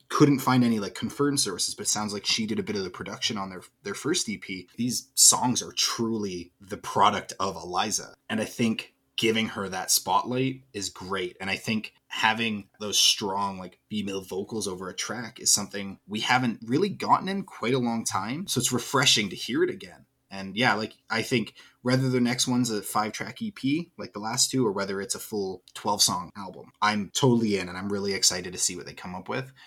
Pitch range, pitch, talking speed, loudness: 100-125 Hz, 110 Hz, 215 wpm, -26 LUFS